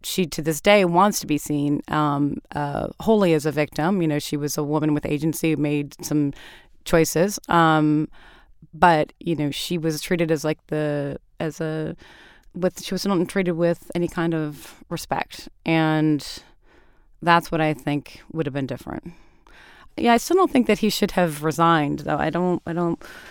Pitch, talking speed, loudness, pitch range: 160 Hz, 185 wpm, -22 LUFS, 150-175 Hz